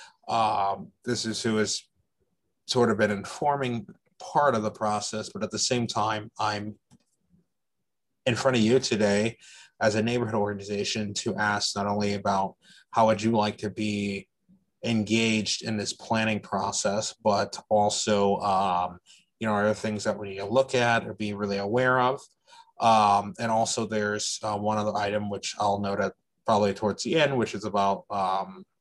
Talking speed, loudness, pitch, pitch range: 175 wpm, -26 LUFS, 105 Hz, 105-115 Hz